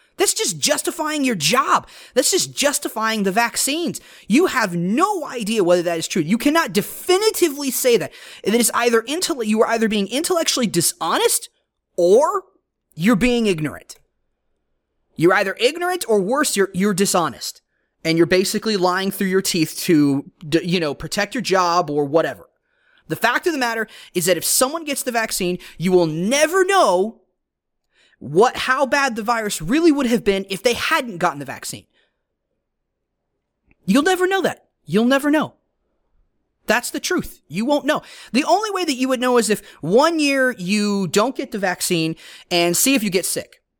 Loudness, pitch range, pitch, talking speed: -19 LUFS, 190-300 Hz, 235 Hz, 175 wpm